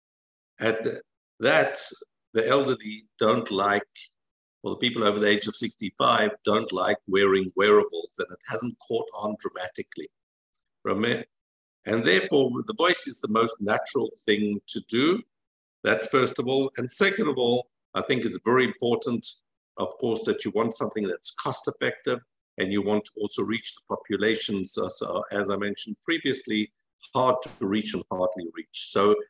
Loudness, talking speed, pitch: -26 LUFS, 160 wpm, 110 Hz